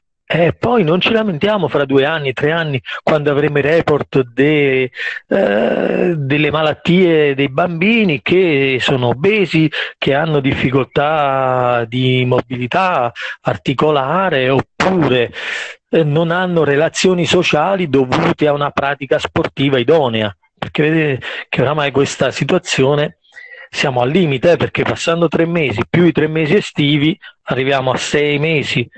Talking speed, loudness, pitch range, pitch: 135 wpm, -14 LUFS, 135-170 Hz, 150 Hz